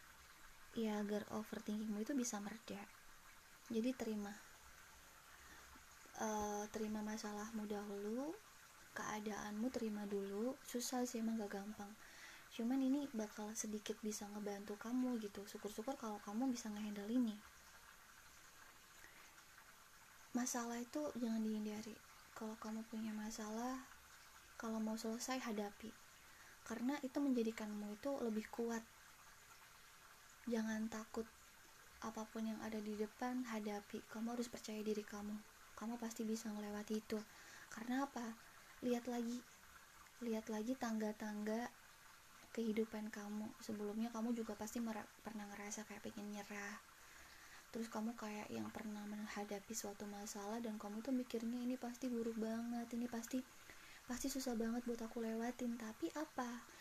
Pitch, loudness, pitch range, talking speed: 220 Hz, -46 LUFS, 210-235 Hz, 120 wpm